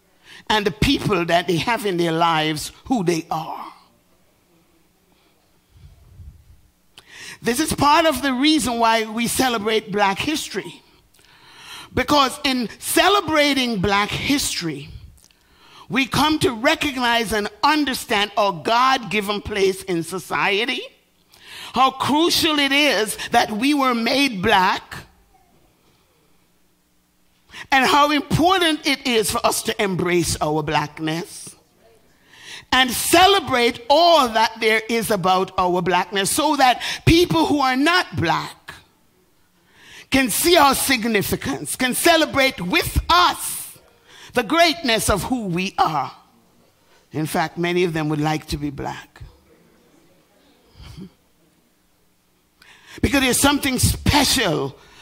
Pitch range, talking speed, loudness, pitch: 180-280 Hz, 115 wpm, -18 LUFS, 230 Hz